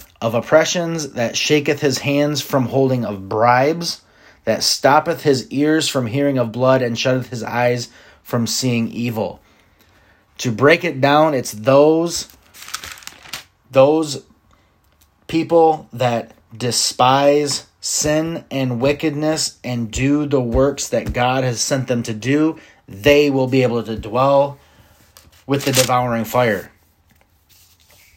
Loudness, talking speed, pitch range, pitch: -17 LUFS, 125 wpm, 115-145 Hz, 130 Hz